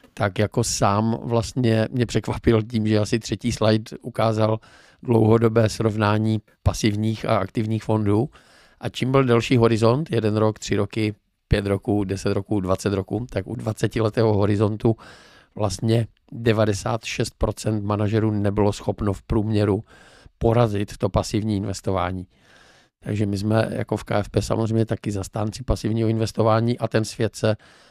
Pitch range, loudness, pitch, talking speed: 105-115 Hz, -22 LUFS, 110 Hz, 135 wpm